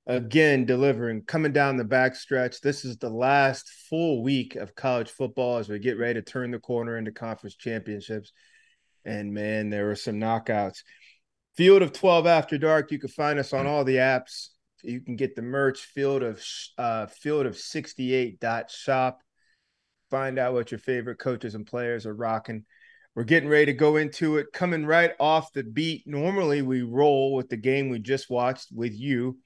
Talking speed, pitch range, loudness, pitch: 185 wpm, 120-145 Hz, -25 LUFS, 130 Hz